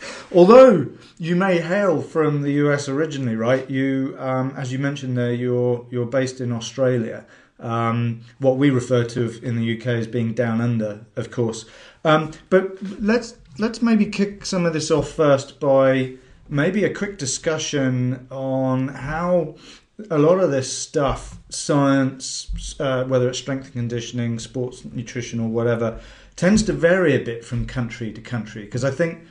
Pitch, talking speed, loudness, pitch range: 130 Hz, 165 wpm, -21 LUFS, 120-155 Hz